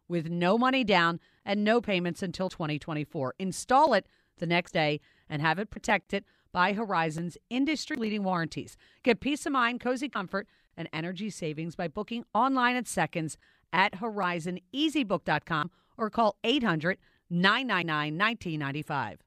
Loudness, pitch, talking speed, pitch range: -29 LUFS, 185 Hz, 135 wpm, 165-220 Hz